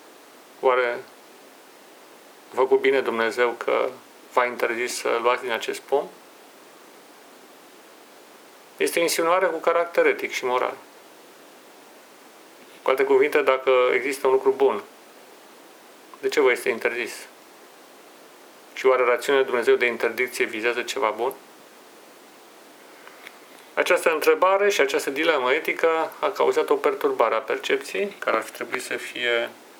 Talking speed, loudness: 125 wpm, -22 LUFS